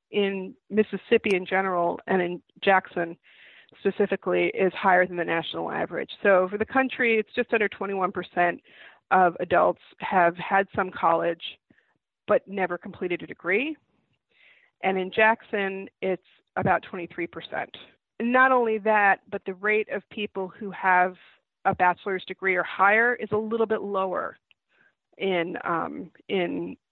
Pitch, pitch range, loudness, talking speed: 195 Hz, 180-215 Hz, -25 LUFS, 140 wpm